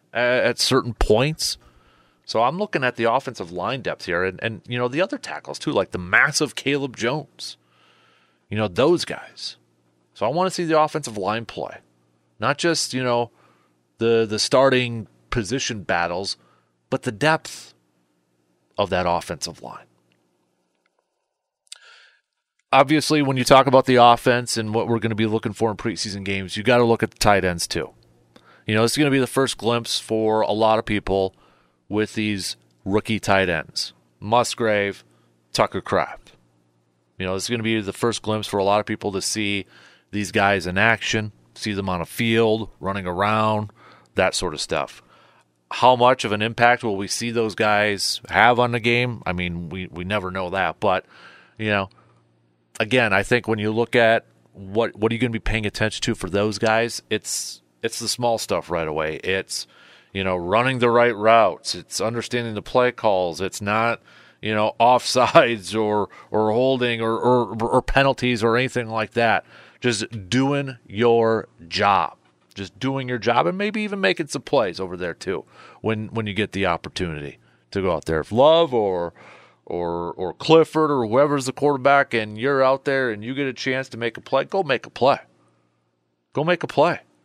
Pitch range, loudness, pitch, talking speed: 95-125 Hz, -21 LUFS, 110 Hz, 190 wpm